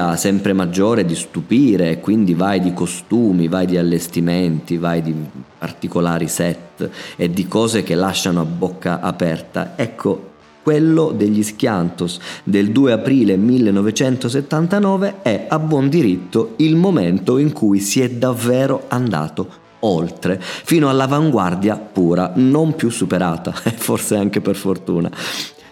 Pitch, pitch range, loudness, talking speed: 100 Hz, 90-130 Hz, -17 LUFS, 130 wpm